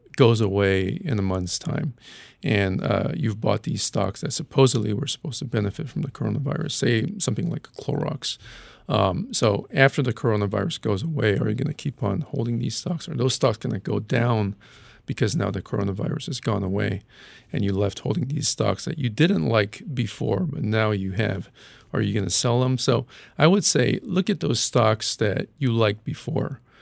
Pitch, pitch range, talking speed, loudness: 120 Hz, 105-145 Hz, 195 wpm, -24 LUFS